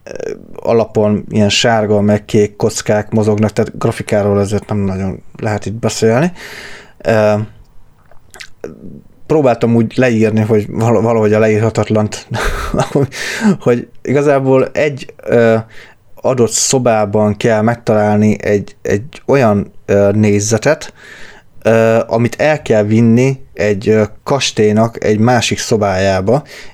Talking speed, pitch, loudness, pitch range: 95 wpm, 110 Hz, -13 LUFS, 105-115 Hz